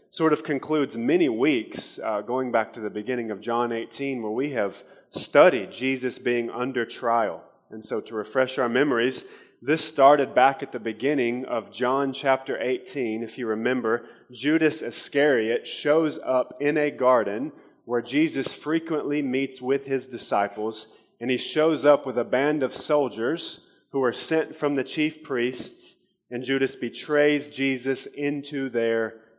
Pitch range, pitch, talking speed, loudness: 120-150 Hz, 135 Hz, 155 wpm, -25 LUFS